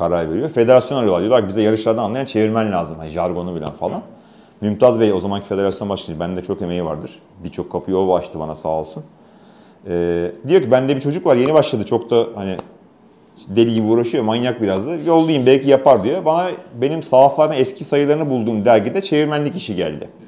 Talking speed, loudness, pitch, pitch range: 185 wpm, -17 LUFS, 110 Hz, 90-135 Hz